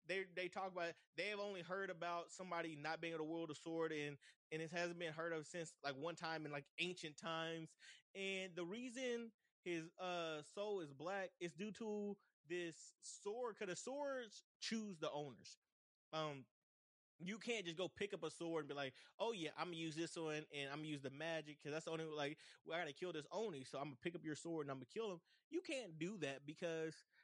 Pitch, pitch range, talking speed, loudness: 165 Hz, 155-190 Hz, 230 wpm, -48 LUFS